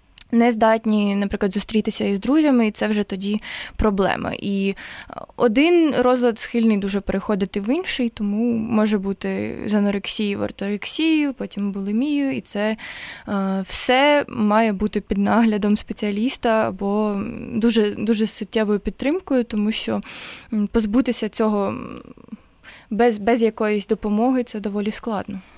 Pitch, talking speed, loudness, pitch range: 215 Hz, 120 wpm, -21 LUFS, 205-235 Hz